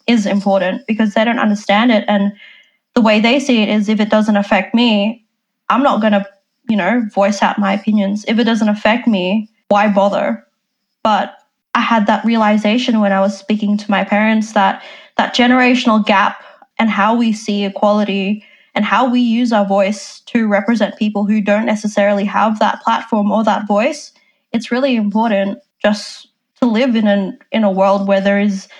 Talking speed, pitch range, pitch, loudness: 185 wpm, 205-230 Hz, 215 Hz, -14 LUFS